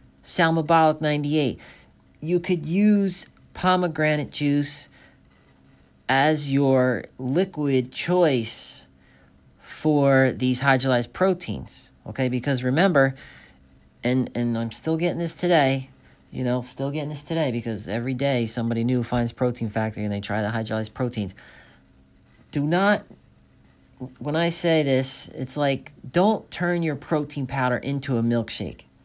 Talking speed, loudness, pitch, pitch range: 125 wpm, -23 LUFS, 130 Hz, 115-155 Hz